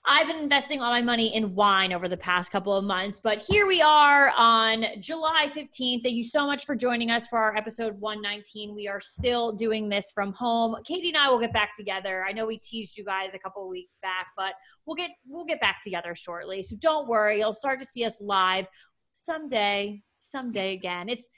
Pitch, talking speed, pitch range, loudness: 220 Hz, 220 wpm, 200-260 Hz, -25 LUFS